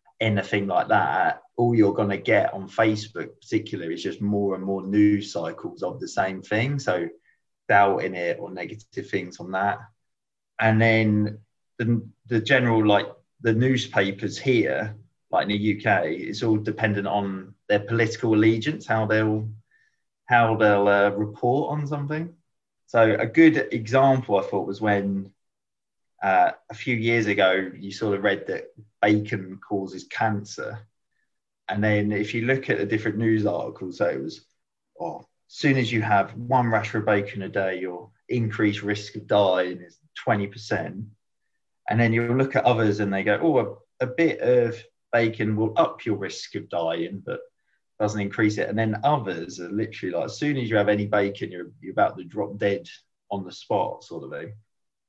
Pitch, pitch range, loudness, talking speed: 110 Hz, 100-115 Hz, -24 LUFS, 180 wpm